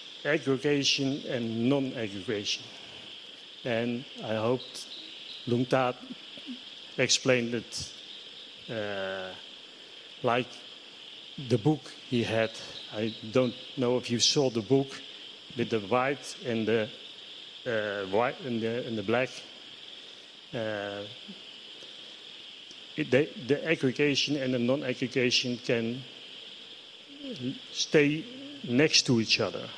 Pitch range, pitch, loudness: 115-140 Hz, 125 Hz, -29 LUFS